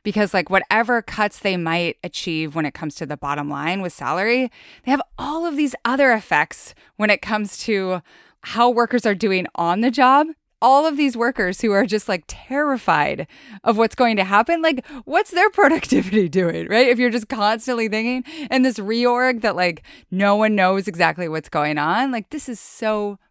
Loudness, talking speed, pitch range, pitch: -19 LUFS, 195 wpm, 185-255 Hz, 215 Hz